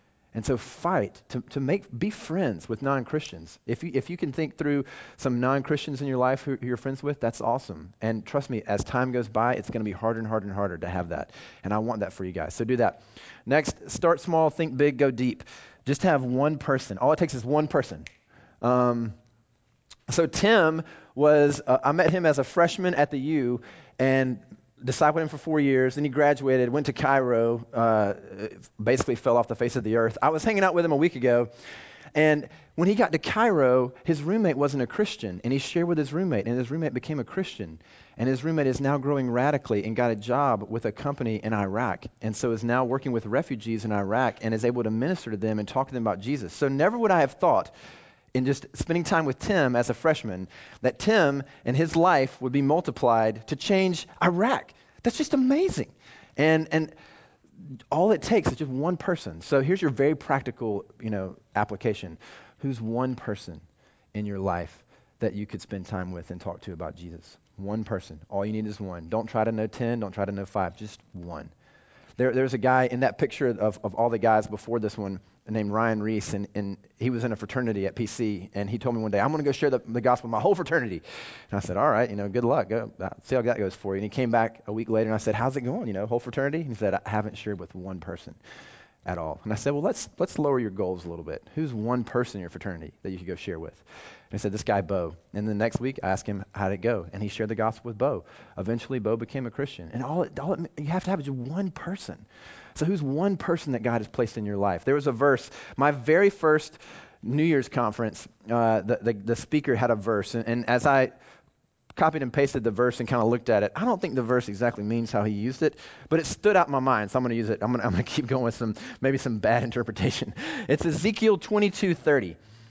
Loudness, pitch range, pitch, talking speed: -26 LUFS, 110-145 Hz, 125 Hz, 245 wpm